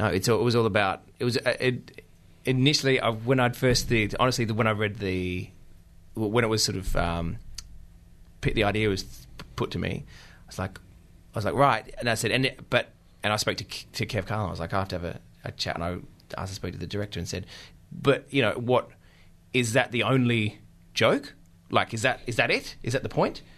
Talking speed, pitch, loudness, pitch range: 230 wpm, 105 Hz, -26 LUFS, 90-115 Hz